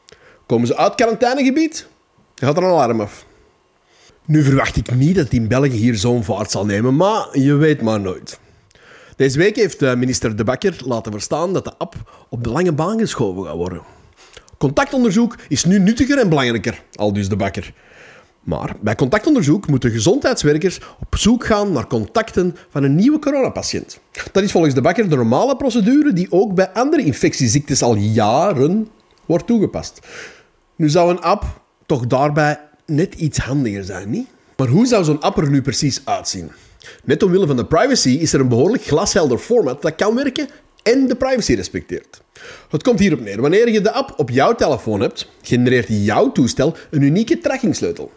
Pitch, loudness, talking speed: 150 Hz, -16 LUFS, 175 wpm